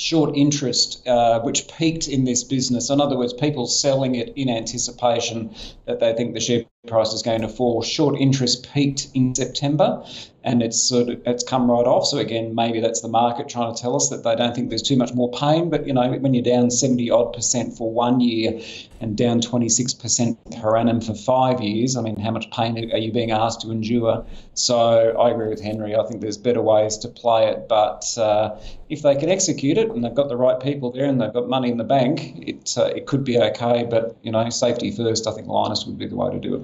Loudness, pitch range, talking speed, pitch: -20 LUFS, 115-130 Hz, 235 wpm, 120 Hz